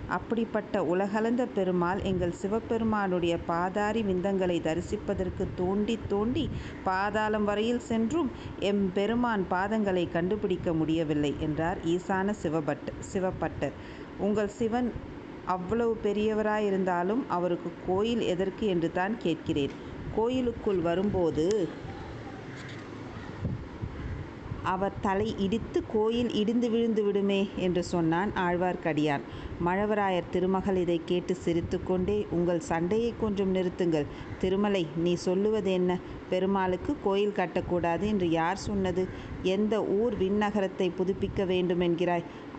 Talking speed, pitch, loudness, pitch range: 95 wpm, 190 Hz, -29 LUFS, 175-210 Hz